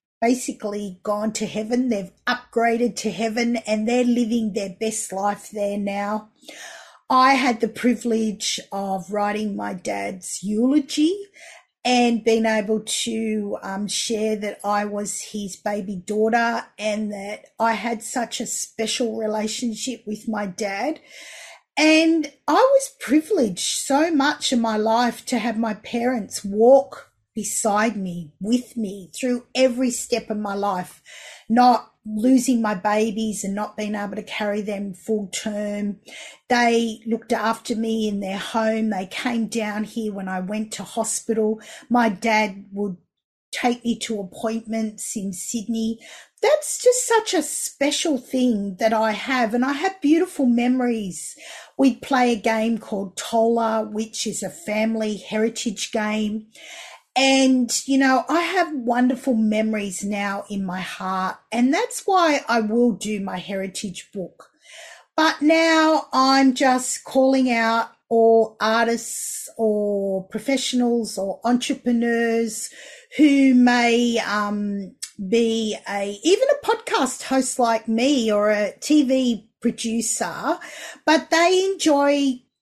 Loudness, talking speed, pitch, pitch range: -21 LUFS, 135 wpm, 225 Hz, 210-255 Hz